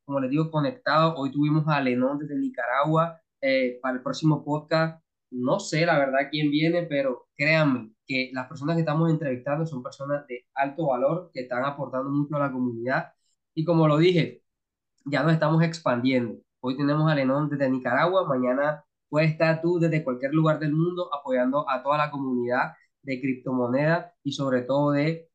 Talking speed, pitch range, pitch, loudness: 180 wpm, 130-160 Hz, 145 Hz, -25 LUFS